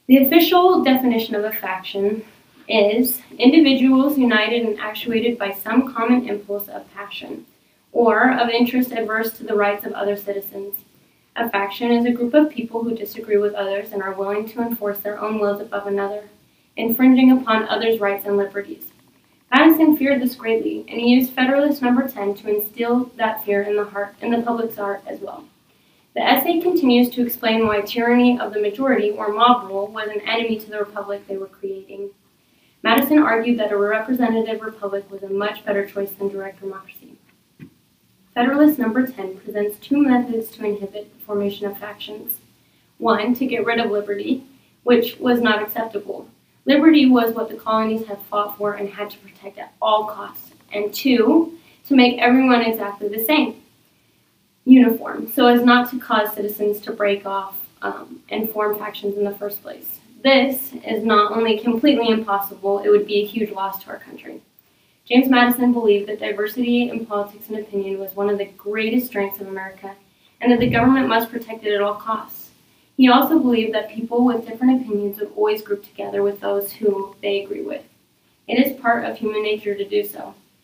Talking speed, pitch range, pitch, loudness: 185 wpm, 205-245 Hz, 220 Hz, -19 LUFS